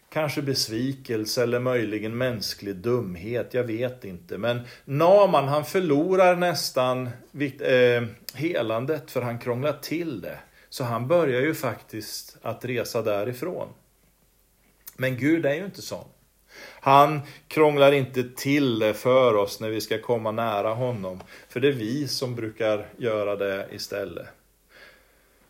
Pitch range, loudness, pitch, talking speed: 110-140 Hz, -24 LUFS, 125 Hz, 135 wpm